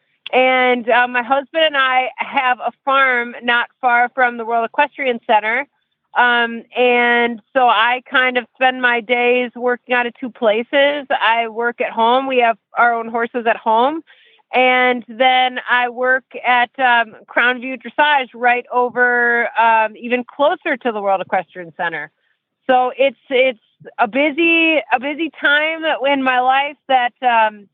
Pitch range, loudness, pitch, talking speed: 235-265 Hz, -16 LUFS, 245 Hz, 160 wpm